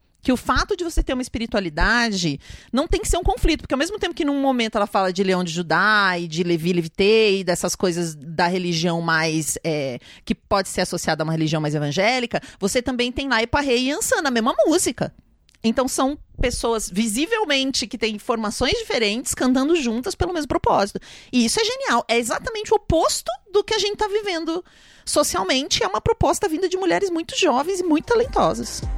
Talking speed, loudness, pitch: 195 wpm, -21 LUFS, 250 Hz